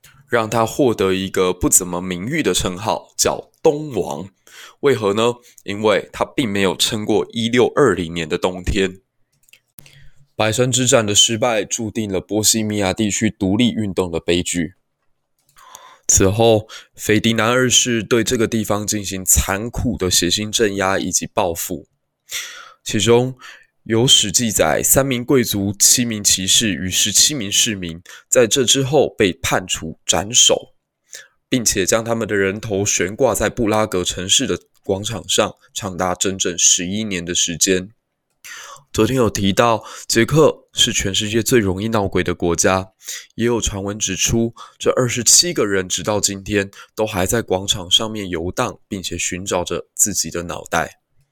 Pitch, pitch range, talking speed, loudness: 105 Hz, 95-120 Hz, 225 characters per minute, -17 LUFS